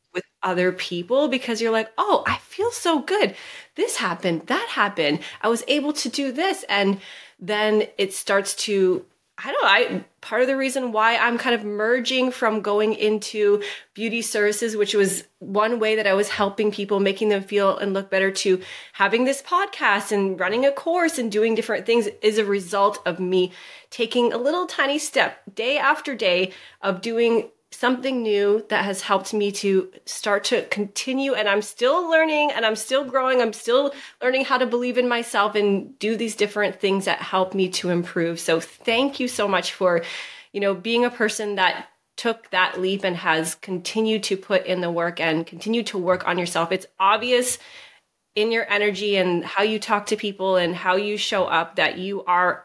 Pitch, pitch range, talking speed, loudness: 210 Hz, 195-245 Hz, 195 wpm, -22 LUFS